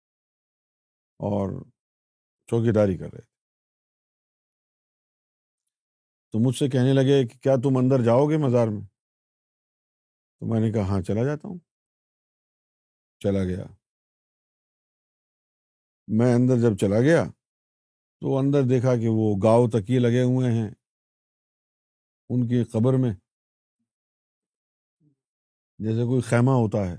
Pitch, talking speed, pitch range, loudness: 115 Hz, 115 wpm, 100-130 Hz, -23 LUFS